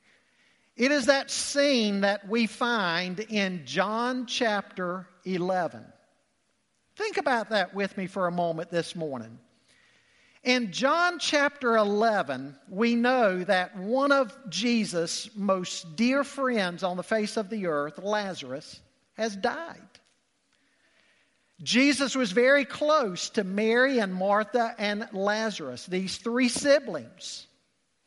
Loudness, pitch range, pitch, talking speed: -27 LUFS, 185-250 Hz, 215 Hz, 120 wpm